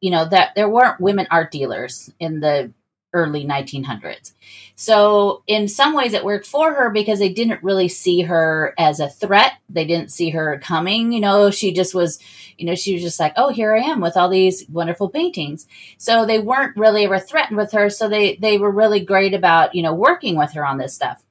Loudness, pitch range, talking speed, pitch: -17 LUFS, 165-215 Hz, 215 wpm, 195 Hz